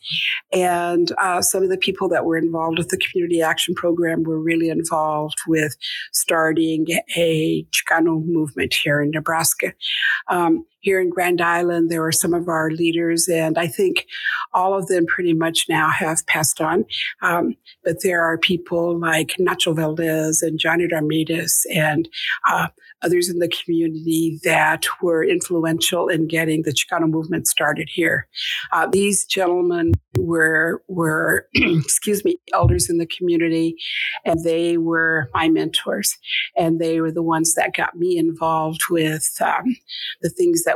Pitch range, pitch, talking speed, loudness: 160-175 Hz, 165 Hz, 155 wpm, -19 LUFS